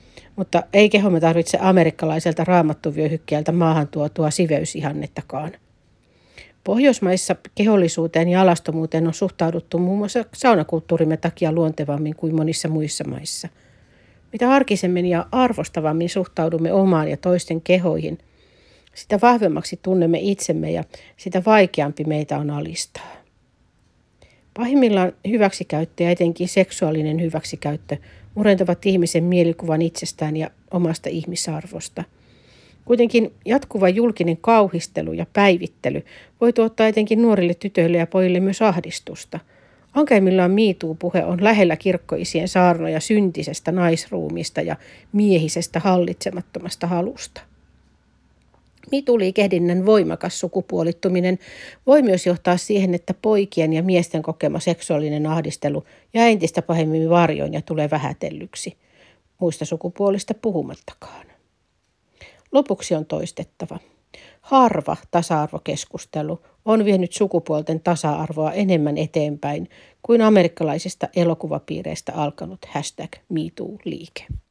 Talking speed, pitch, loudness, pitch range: 100 wpm, 175 Hz, -20 LUFS, 160-195 Hz